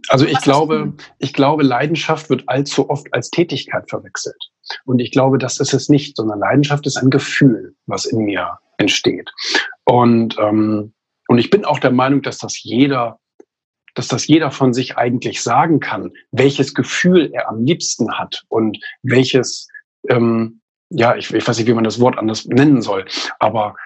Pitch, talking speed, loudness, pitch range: 130 Hz, 175 wpm, -16 LUFS, 120-145 Hz